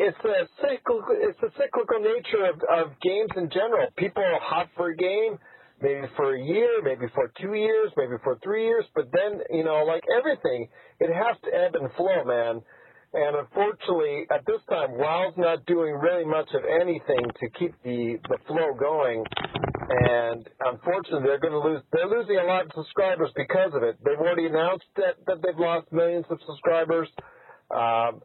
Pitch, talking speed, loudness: 185 Hz, 185 wpm, -25 LUFS